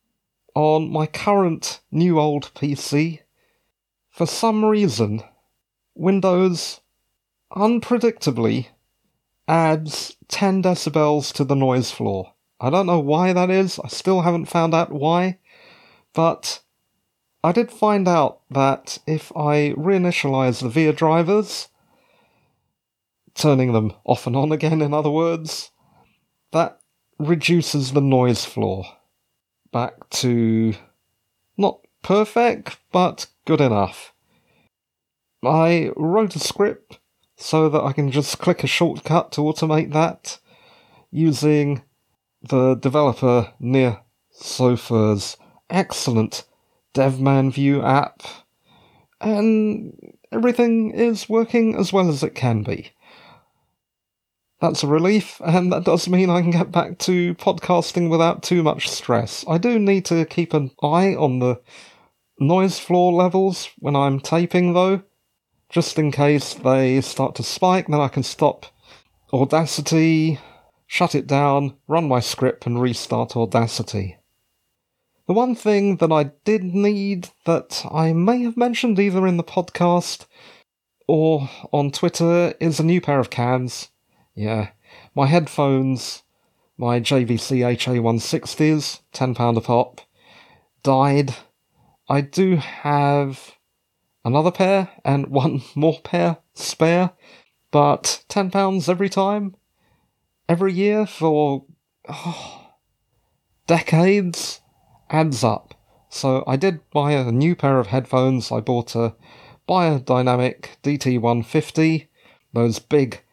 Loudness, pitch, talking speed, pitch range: -20 LUFS, 155 Hz, 120 wpm, 130-175 Hz